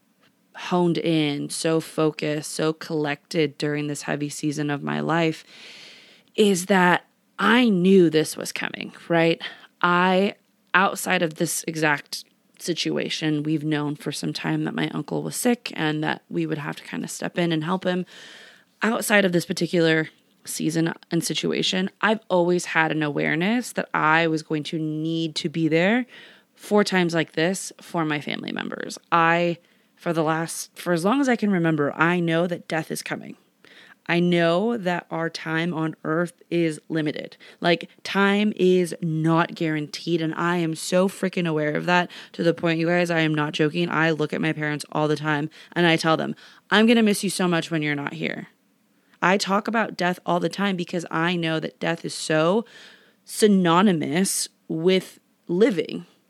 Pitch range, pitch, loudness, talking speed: 155-185 Hz, 170 Hz, -23 LUFS, 180 wpm